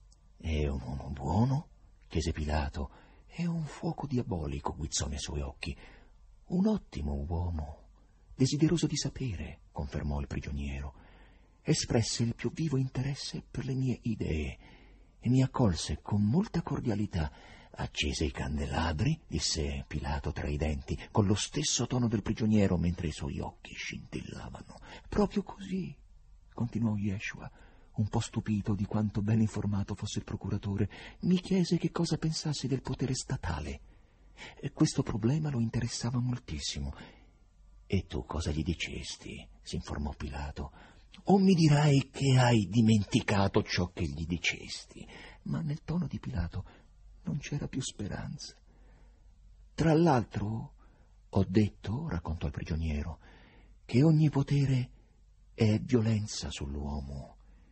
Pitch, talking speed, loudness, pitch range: 100 Hz, 130 wpm, -32 LUFS, 80-125 Hz